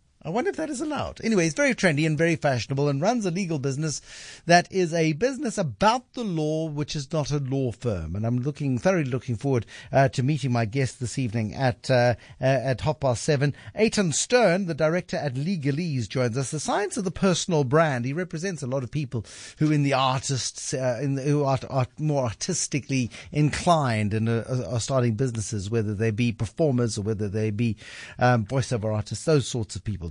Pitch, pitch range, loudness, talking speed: 140 Hz, 120-160 Hz, -25 LUFS, 205 wpm